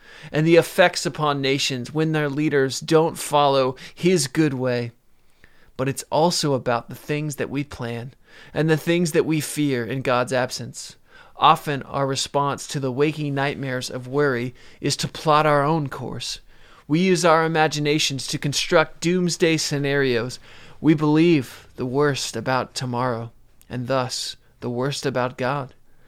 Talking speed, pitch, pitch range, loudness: 150 wpm, 140 Hz, 125-155 Hz, -22 LUFS